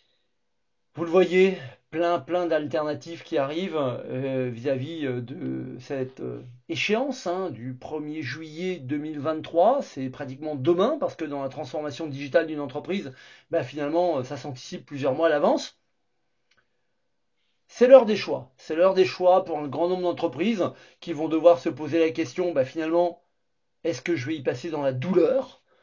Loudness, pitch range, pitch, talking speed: -25 LUFS, 145-175 Hz, 160 Hz, 160 wpm